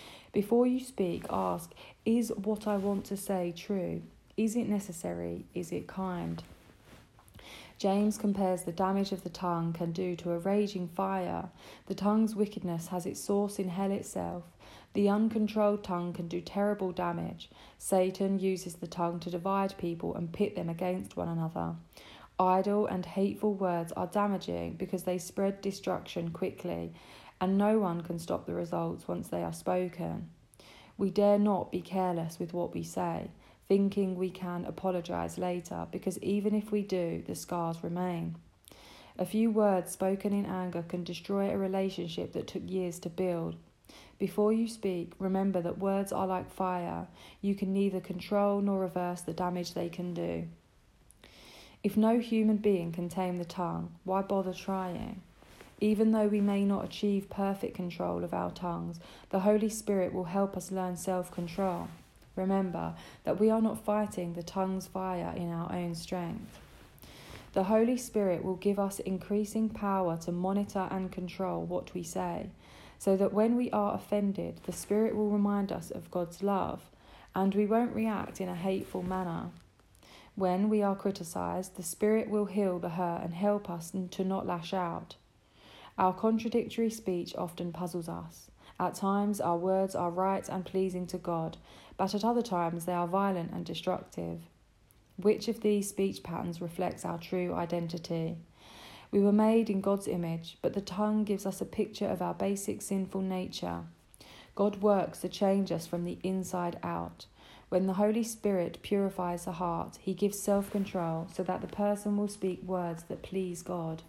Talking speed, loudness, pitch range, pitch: 165 wpm, -33 LUFS, 175-200 Hz, 185 Hz